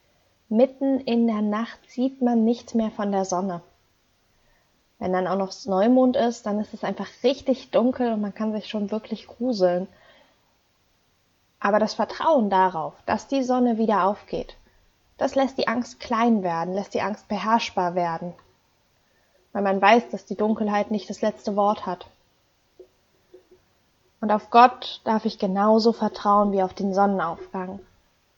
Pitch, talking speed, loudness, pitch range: 210 Hz, 150 wpm, -23 LUFS, 185-230 Hz